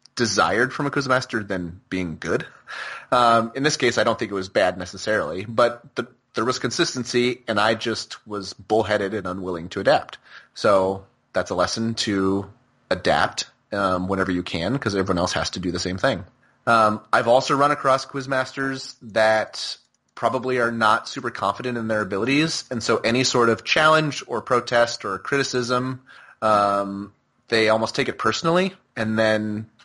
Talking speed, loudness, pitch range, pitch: 170 wpm, -22 LUFS, 100-130 Hz, 115 Hz